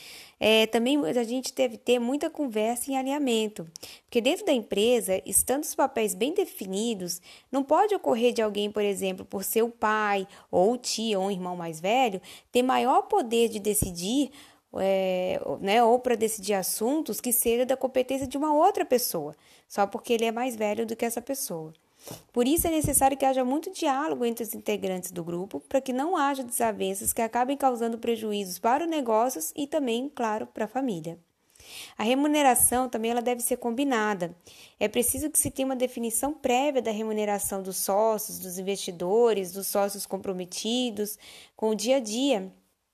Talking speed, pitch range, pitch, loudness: 175 wpm, 205-265 Hz, 235 Hz, -26 LUFS